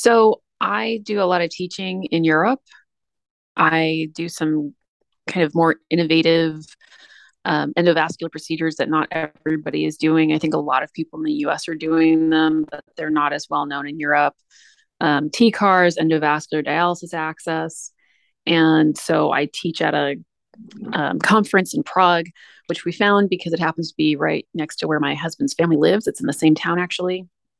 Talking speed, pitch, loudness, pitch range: 175 wpm, 160 Hz, -19 LUFS, 155-180 Hz